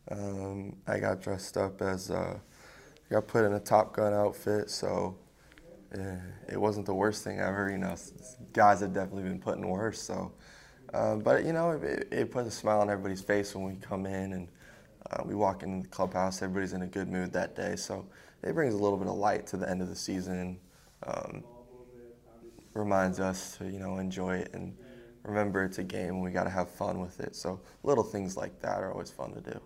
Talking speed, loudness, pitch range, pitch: 215 wpm, -33 LUFS, 95-105 Hz, 100 Hz